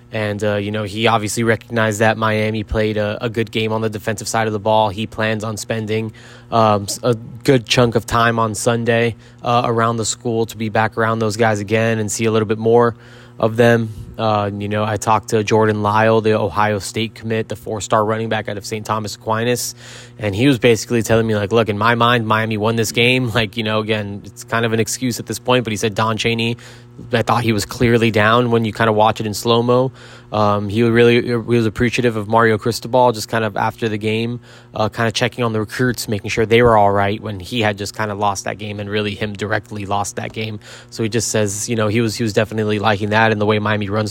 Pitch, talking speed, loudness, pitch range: 110 Hz, 250 wpm, -17 LUFS, 110-120 Hz